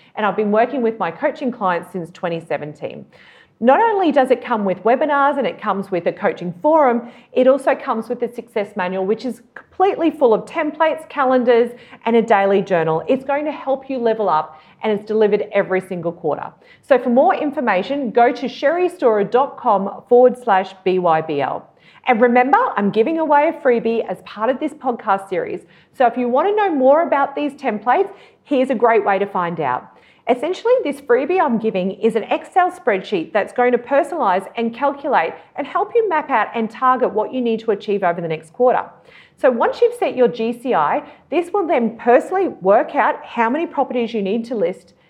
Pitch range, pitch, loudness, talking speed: 205-285 Hz, 245 Hz, -18 LUFS, 195 wpm